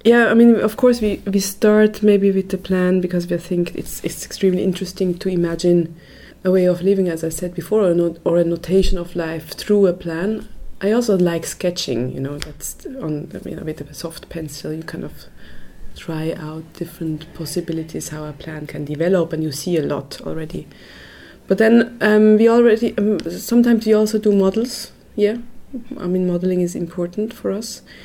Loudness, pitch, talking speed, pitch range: -18 LUFS, 180 Hz, 200 wpm, 165-210 Hz